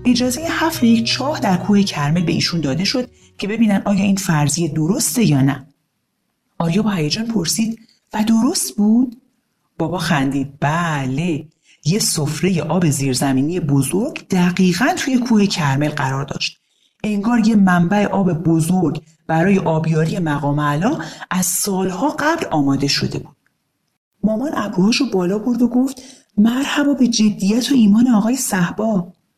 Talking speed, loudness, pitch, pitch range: 140 wpm, -17 LUFS, 190 Hz, 160-230 Hz